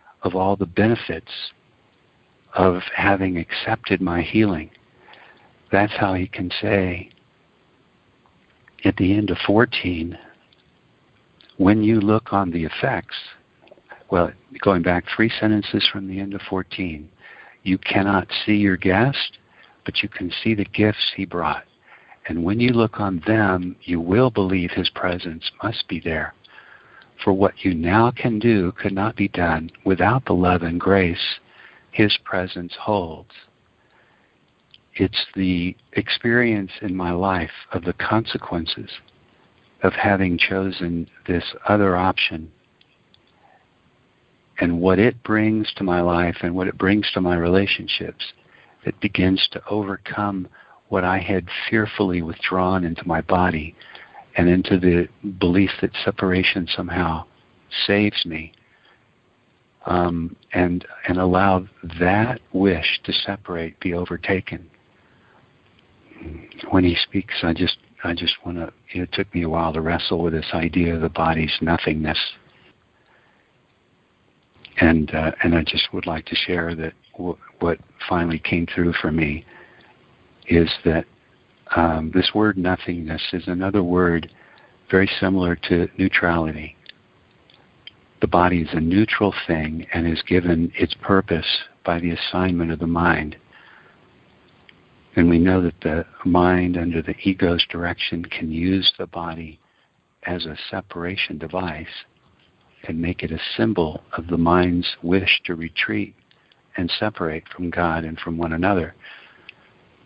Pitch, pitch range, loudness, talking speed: 90 Hz, 85-100 Hz, -21 LUFS, 135 wpm